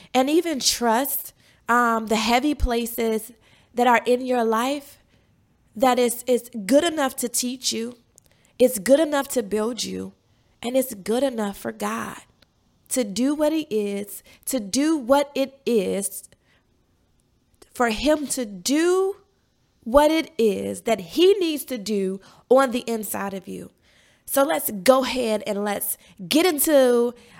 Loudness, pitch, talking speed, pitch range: -22 LUFS, 245 Hz, 145 wpm, 220-275 Hz